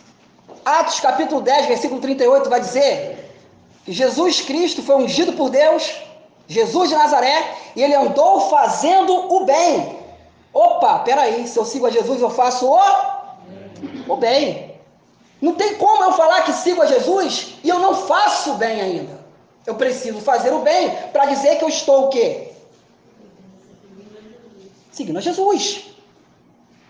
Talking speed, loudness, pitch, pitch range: 145 wpm, -16 LUFS, 305 Hz, 260-365 Hz